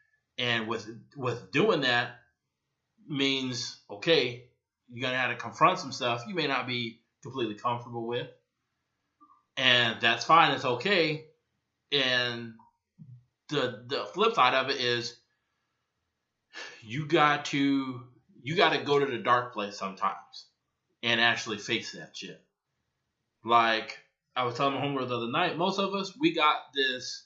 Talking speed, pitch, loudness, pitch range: 145 wpm, 125 Hz, -27 LUFS, 120-145 Hz